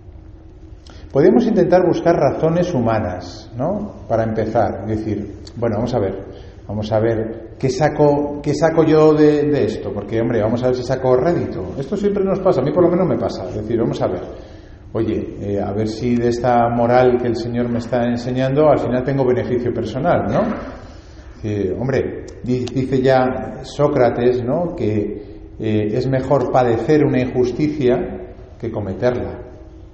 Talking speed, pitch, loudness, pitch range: 165 wpm, 120 Hz, -18 LUFS, 105-130 Hz